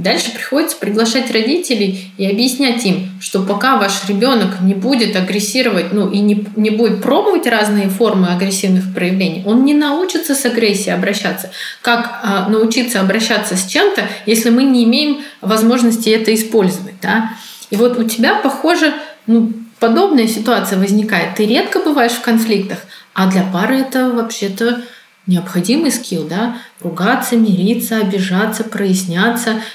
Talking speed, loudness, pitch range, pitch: 140 wpm, -14 LUFS, 200-245 Hz, 220 Hz